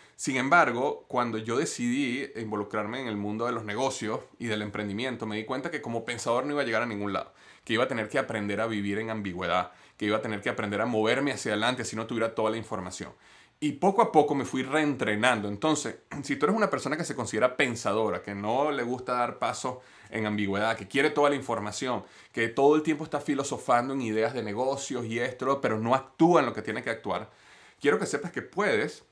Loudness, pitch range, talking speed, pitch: -28 LUFS, 110-140 Hz, 225 wpm, 120 Hz